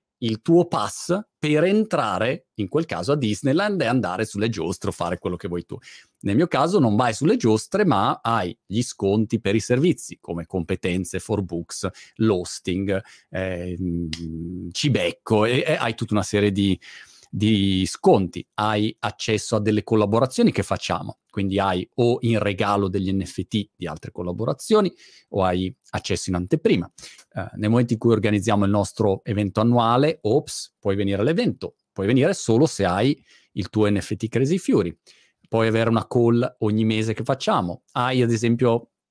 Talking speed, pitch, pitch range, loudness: 165 wpm, 110 Hz, 95-120 Hz, -22 LUFS